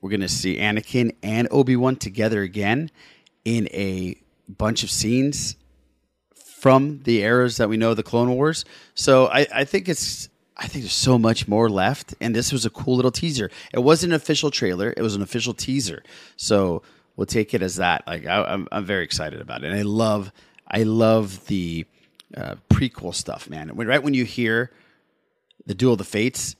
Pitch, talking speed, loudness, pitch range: 115 Hz, 190 wpm, -21 LUFS, 105-130 Hz